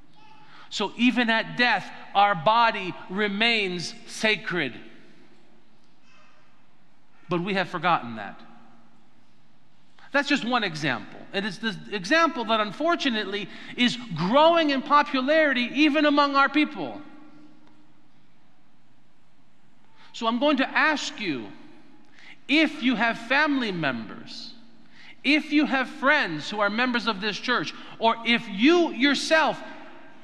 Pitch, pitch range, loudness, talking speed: 245 Hz, 215-290 Hz, -23 LUFS, 110 wpm